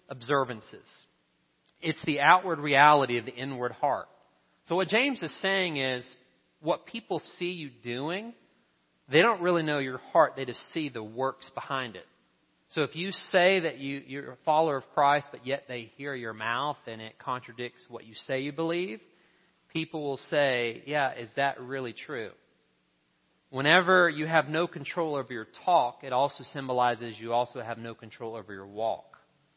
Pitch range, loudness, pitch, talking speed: 120-160 Hz, -28 LUFS, 135 Hz, 175 wpm